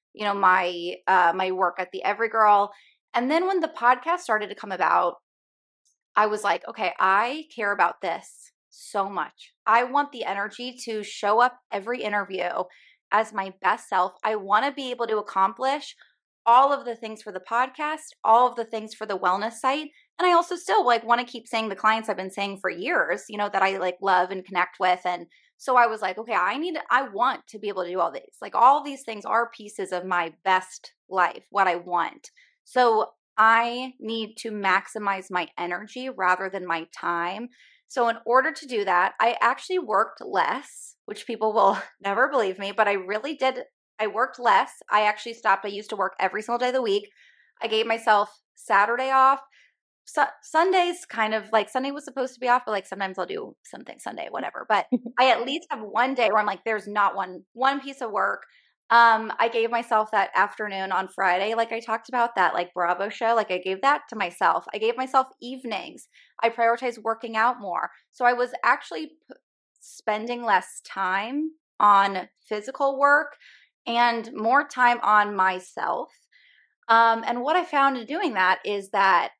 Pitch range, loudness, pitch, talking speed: 195-255 Hz, -24 LUFS, 225 Hz, 200 wpm